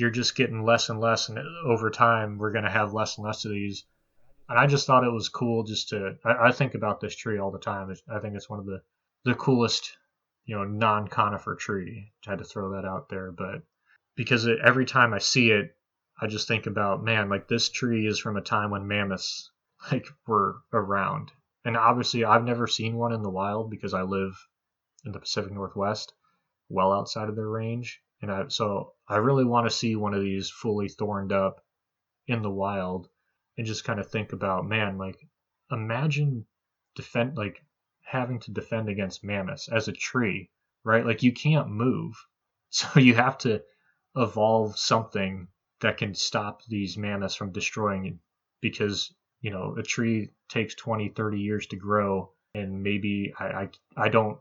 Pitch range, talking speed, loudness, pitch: 100-115 Hz, 190 wpm, -27 LUFS, 110 Hz